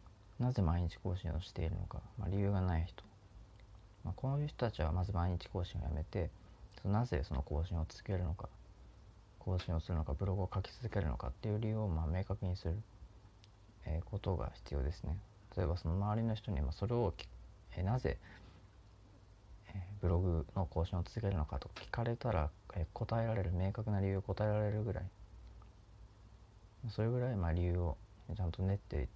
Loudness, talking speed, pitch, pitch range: -39 LUFS, 310 characters per minute, 95 Hz, 85-105 Hz